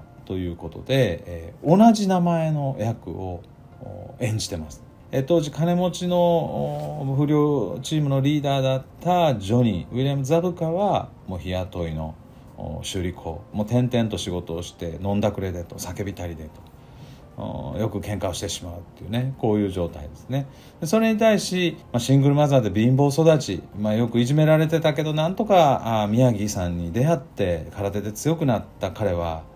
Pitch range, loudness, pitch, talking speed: 95-150 Hz, -23 LUFS, 120 Hz, 345 characters per minute